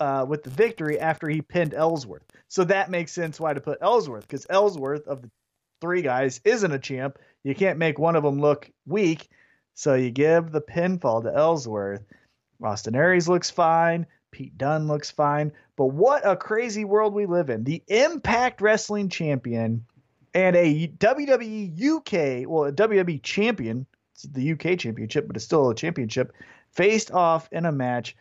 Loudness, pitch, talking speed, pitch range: -24 LUFS, 160 Hz, 175 wpm, 135-185 Hz